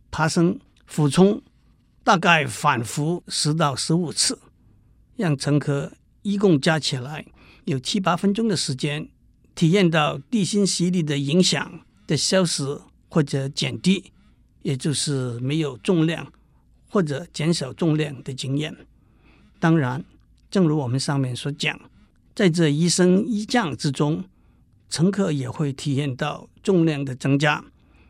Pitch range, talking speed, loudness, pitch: 140-180 Hz, 195 characters per minute, -22 LUFS, 155 Hz